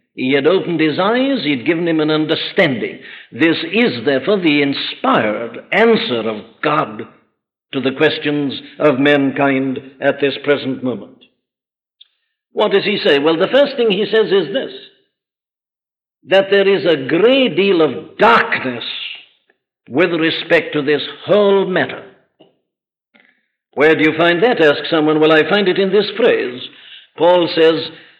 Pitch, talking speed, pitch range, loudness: 160 Hz, 145 wpm, 145-200 Hz, -15 LUFS